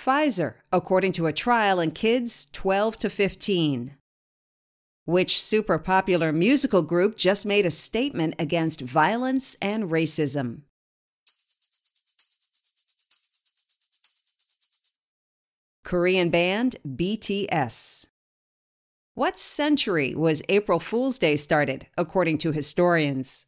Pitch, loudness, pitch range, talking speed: 180 Hz, -23 LUFS, 160-210 Hz, 90 wpm